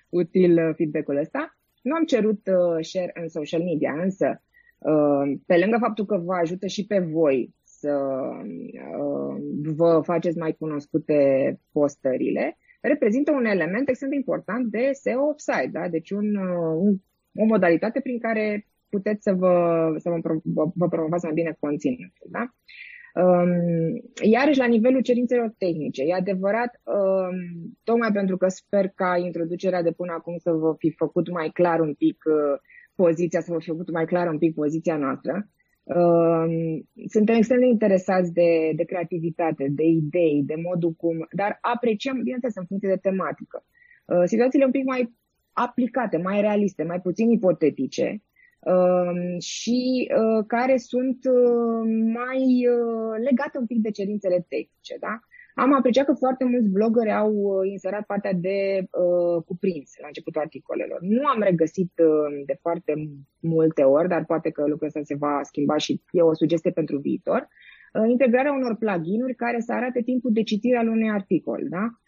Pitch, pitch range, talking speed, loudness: 185 Hz, 165-235 Hz, 160 wpm, -23 LUFS